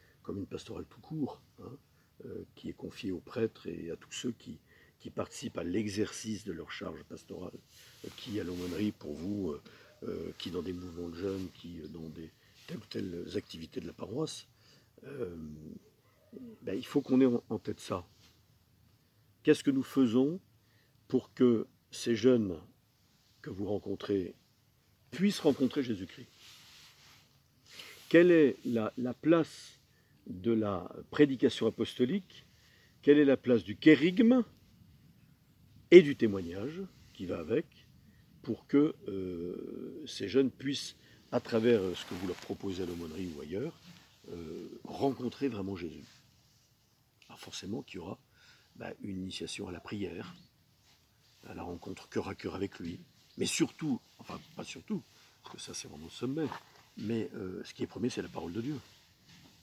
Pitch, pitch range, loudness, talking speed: 115 Hz, 95-130 Hz, -33 LUFS, 155 wpm